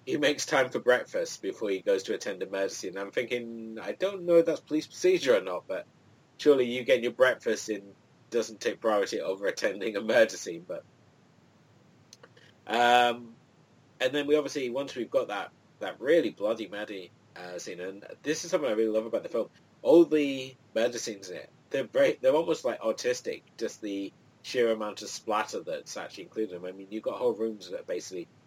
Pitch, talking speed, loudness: 145 Hz, 200 wpm, -29 LUFS